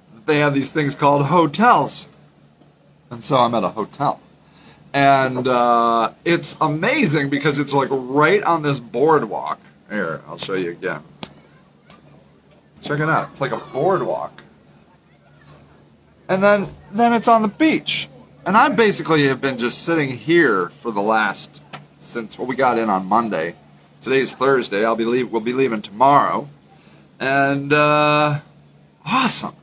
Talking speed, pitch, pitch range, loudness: 145 wpm, 140 Hz, 120-160 Hz, -18 LUFS